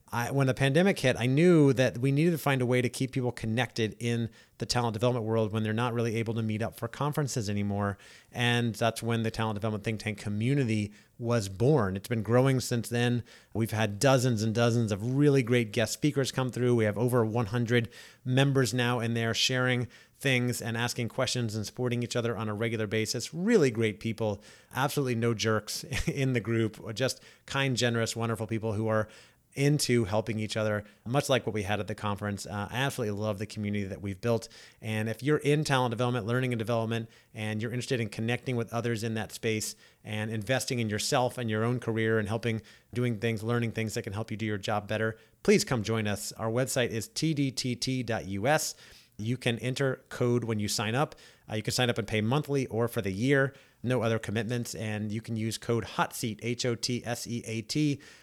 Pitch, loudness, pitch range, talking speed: 115 Hz, -29 LUFS, 110-125 Hz, 210 wpm